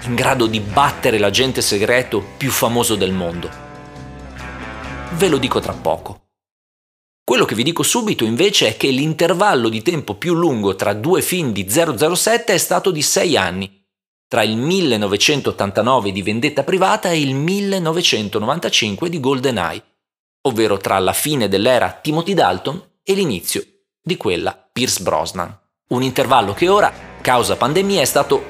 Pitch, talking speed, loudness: 140 Hz, 145 wpm, -16 LUFS